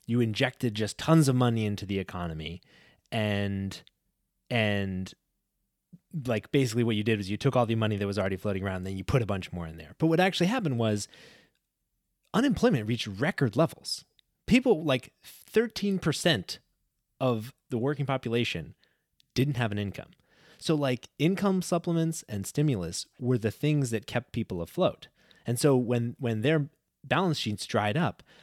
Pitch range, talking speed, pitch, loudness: 105-145 Hz, 165 wpm, 120 Hz, -29 LUFS